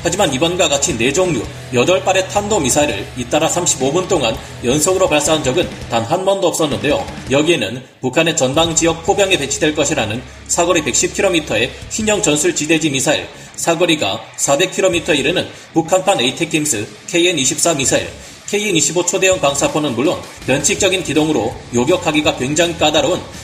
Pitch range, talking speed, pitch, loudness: 140-185 Hz, 345 characters per minute, 165 Hz, -15 LUFS